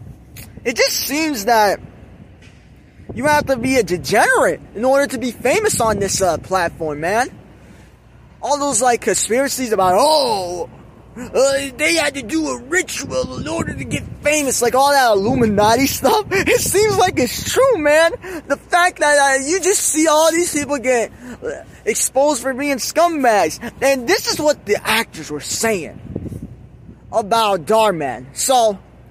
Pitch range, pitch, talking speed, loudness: 230-320 Hz, 275 Hz, 155 wpm, -16 LUFS